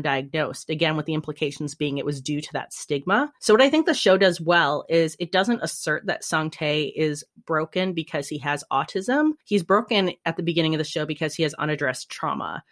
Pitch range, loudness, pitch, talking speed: 150-185 Hz, -23 LUFS, 160 Hz, 215 wpm